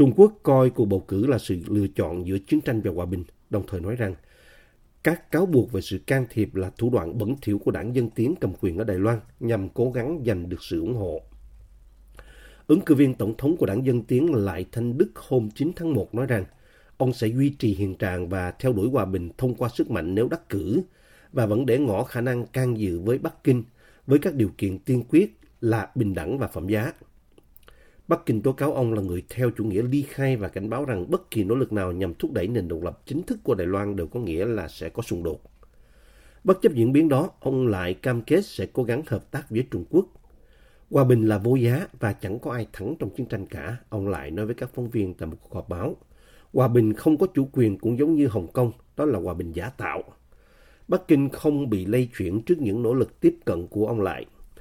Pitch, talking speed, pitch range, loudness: 115 Hz, 245 wpm, 100-130 Hz, -25 LUFS